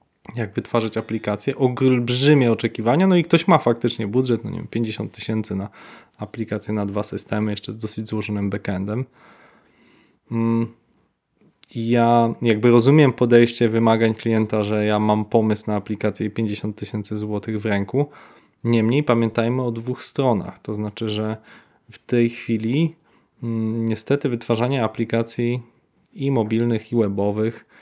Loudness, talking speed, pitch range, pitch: -21 LUFS, 135 wpm, 105-120 Hz, 115 Hz